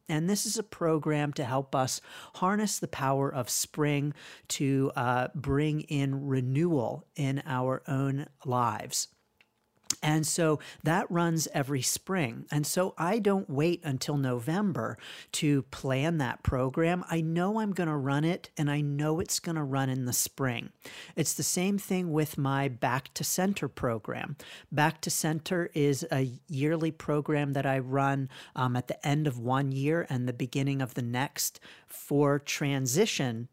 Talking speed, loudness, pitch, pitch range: 165 wpm, -30 LUFS, 145 Hz, 135-160 Hz